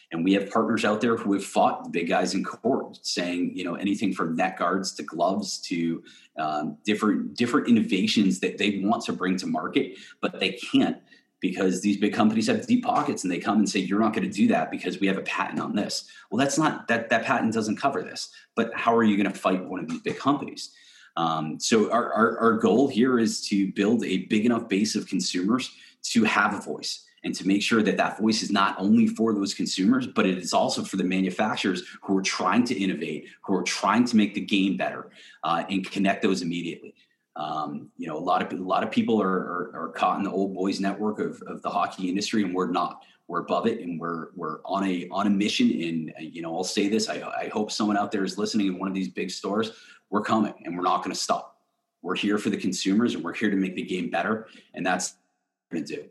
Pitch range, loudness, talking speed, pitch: 95-110 Hz, -25 LUFS, 245 wpm, 100 Hz